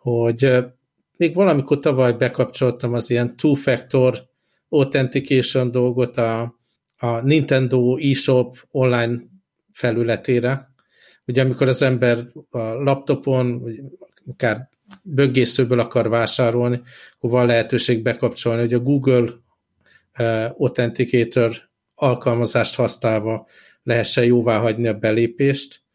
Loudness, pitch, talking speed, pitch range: -19 LUFS, 125 Hz, 95 wpm, 120-135 Hz